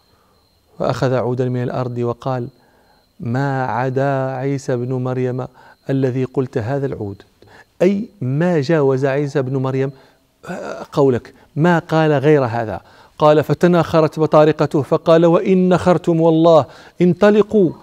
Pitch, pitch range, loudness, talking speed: 140 Hz, 130-160 Hz, -16 LUFS, 110 wpm